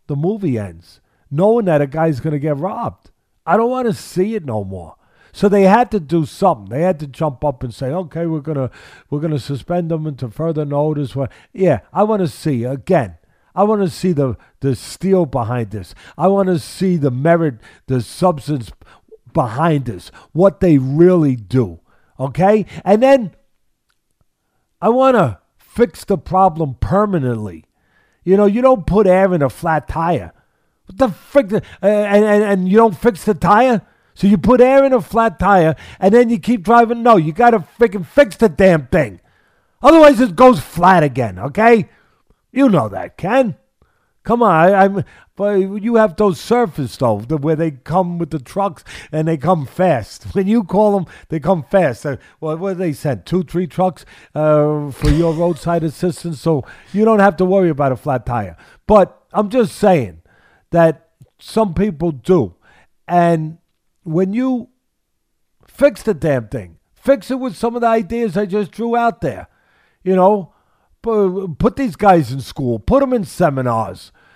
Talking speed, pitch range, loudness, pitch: 175 wpm, 145-210 Hz, -15 LUFS, 175 Hz